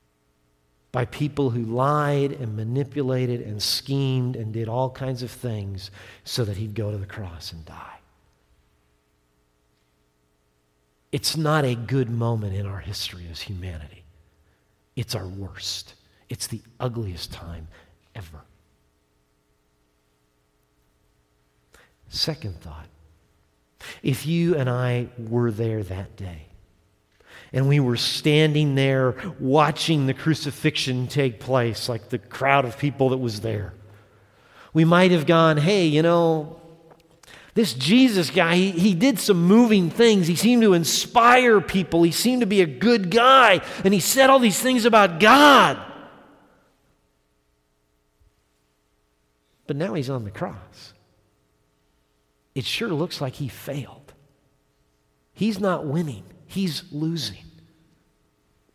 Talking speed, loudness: 125 wpm, -21 LUFS